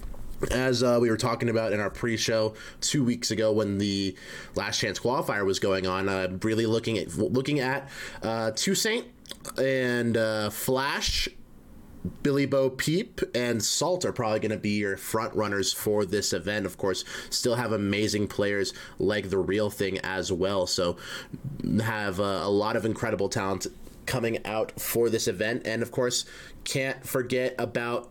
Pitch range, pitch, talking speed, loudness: 105-125 Hz, 110 Hz, 170 wpm, -27 LUFS